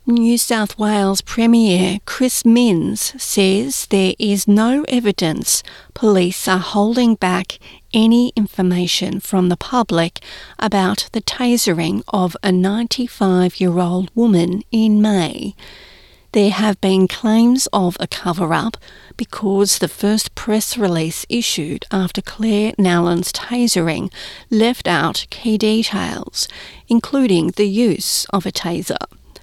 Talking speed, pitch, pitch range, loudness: 115 wpm, 205 Hz, 185-230 Hz, -16 LUFS